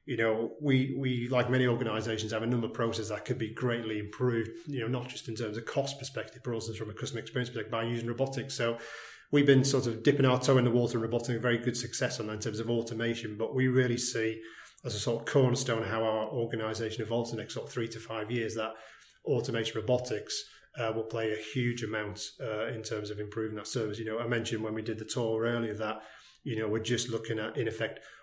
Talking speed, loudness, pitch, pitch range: 245 wpm, -32 LUFS, 115 Hz, 110-125 Hz